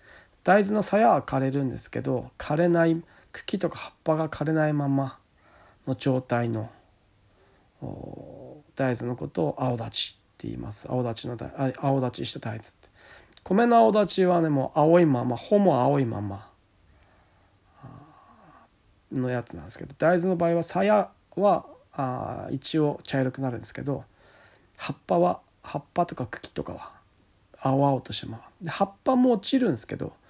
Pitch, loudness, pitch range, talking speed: 135 Hz, -26 LUFS, 115-165 Hz, 285 characters per minute